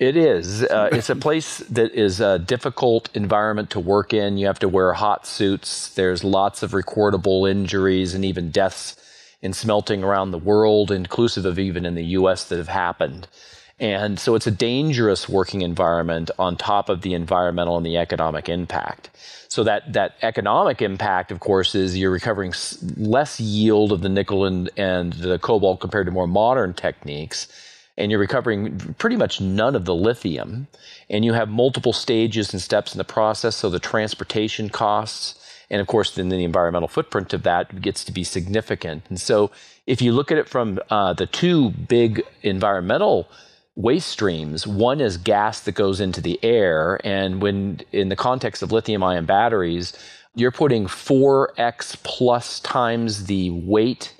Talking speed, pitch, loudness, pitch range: 175 wpm, 100 Hz, -21 LUFS, 95-110 Hz